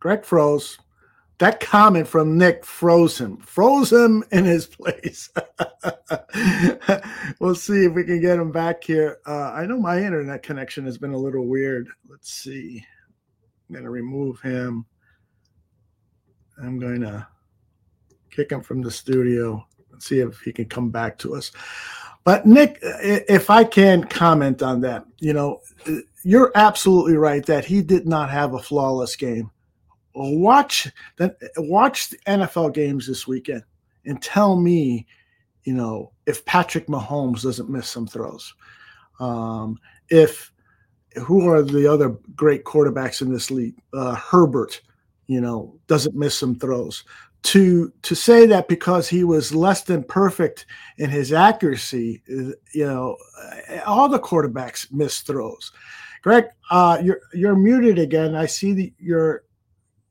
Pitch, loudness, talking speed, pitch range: 150 Hz, -19 LUFS, 145 wpm, 125-180 Hz